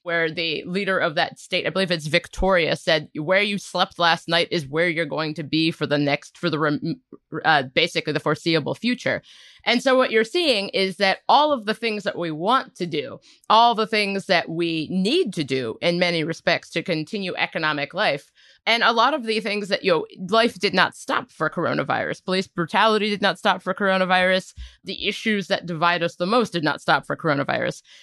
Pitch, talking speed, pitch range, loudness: 185 Hz, 210 wpm, 165-205 Hz, -22 LUFS